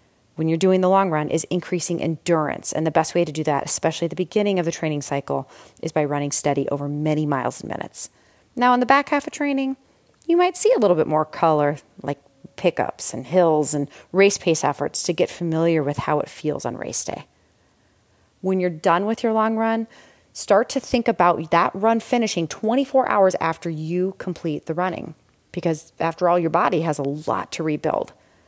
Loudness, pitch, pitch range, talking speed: -21 LUFS, 170 Hz, 155-200 Hz, 205 wpm